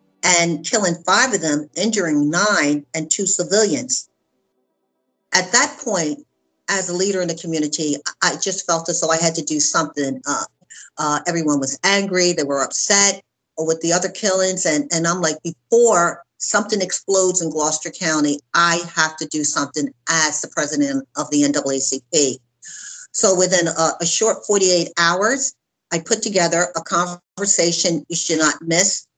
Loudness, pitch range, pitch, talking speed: -18 LUFS, 150-190 Hz, 170 Hz, 160 wpm